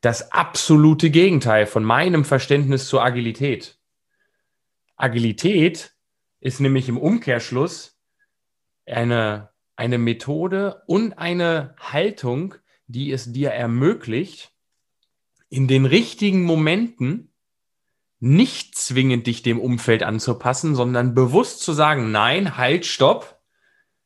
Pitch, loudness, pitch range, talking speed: 135 Hz, -19 LUFS, 120-165 Hz, 100 wpm